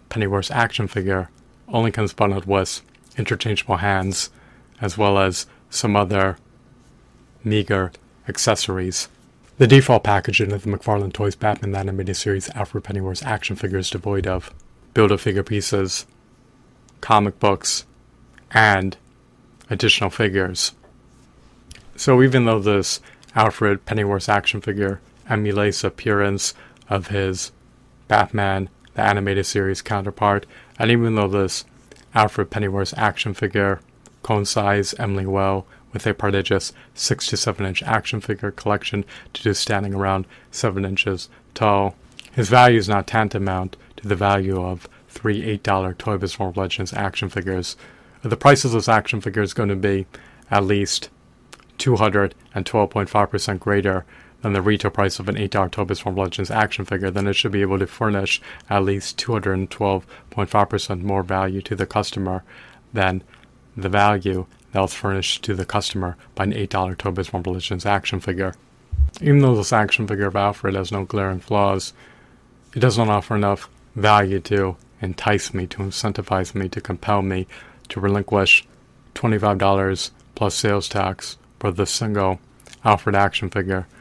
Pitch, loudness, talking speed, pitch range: 100 Hz, -20 LUFS, 150 wpm, 95-110 Hz